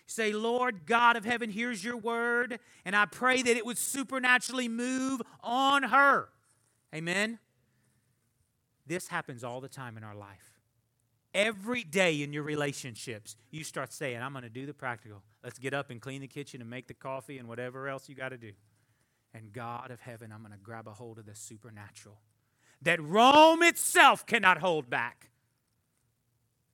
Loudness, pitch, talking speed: -28 LUFS, 135 Hz, 175 wpm